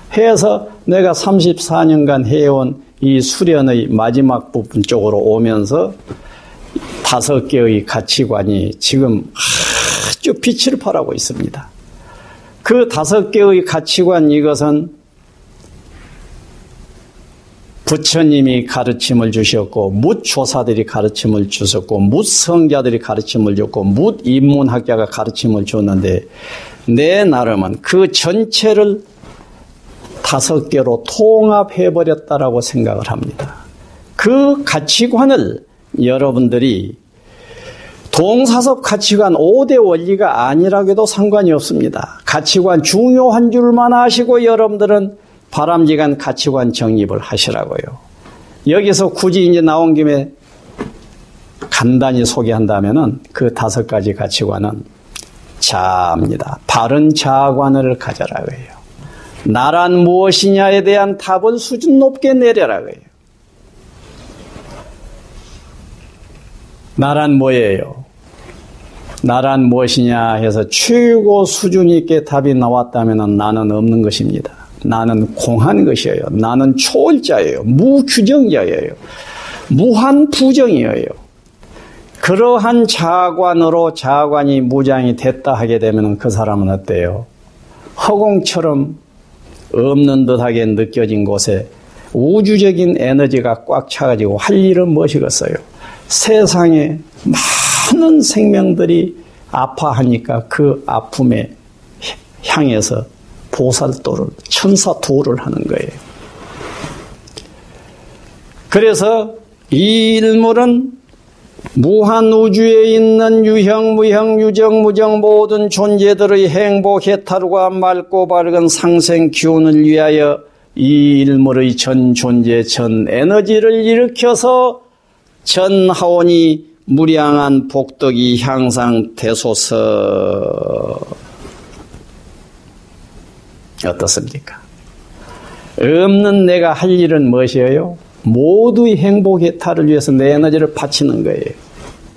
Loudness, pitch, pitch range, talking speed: -11 LUFS, 155 Hz, 125-205 Hz, 225 characters per minute